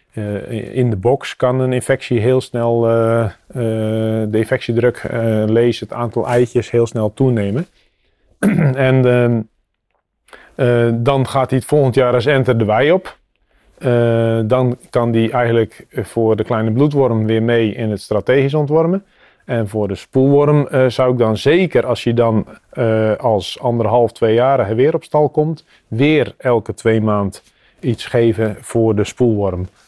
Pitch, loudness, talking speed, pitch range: 120 Hz, -16 LUFS, 160 wpm, 110-130 Hz